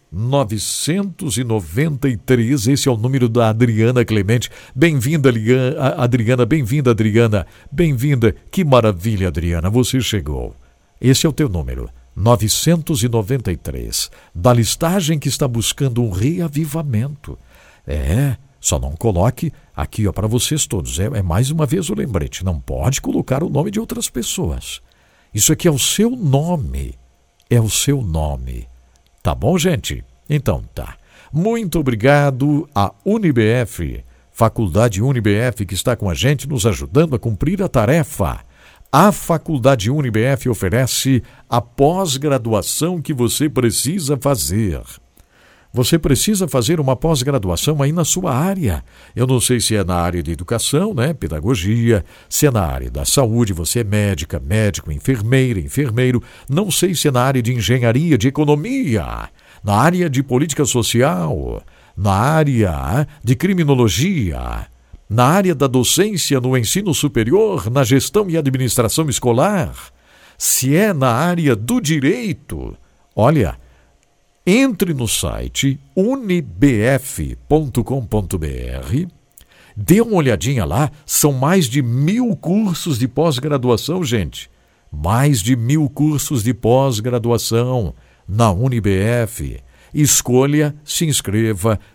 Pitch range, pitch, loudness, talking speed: 105-150 Hz, 125 Hz, -17 LUFS, 125 wpm